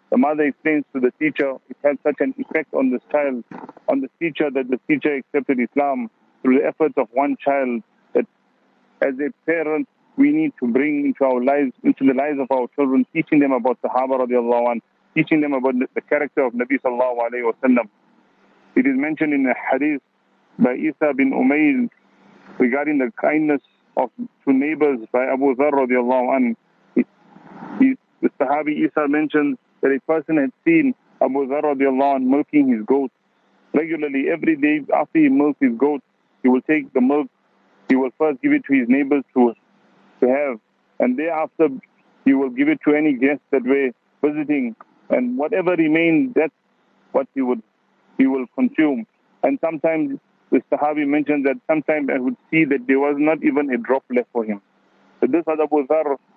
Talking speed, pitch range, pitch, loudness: 180 wpm, 135-190 Hz, 145 Hz, -20 LUFS